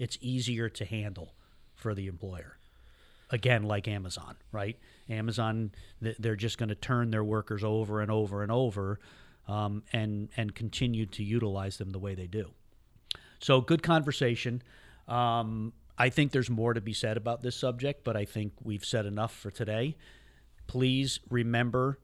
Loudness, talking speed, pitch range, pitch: -32 LUFS, 160 wpm, 105-120 Hz, 110 Hz